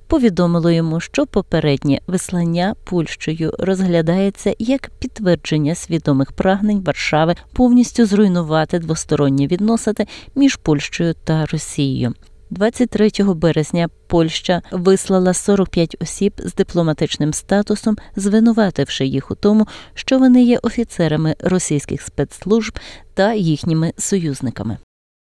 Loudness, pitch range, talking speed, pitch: -17 LUFS, 155-210 Hz, 100 wpm, 175 Hz